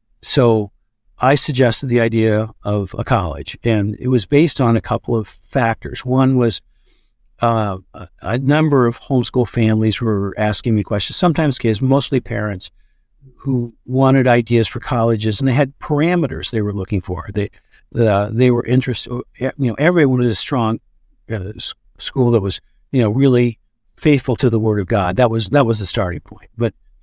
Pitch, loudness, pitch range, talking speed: 115 Hz, -17 LUFS, 110-130 Hz, 175 wpm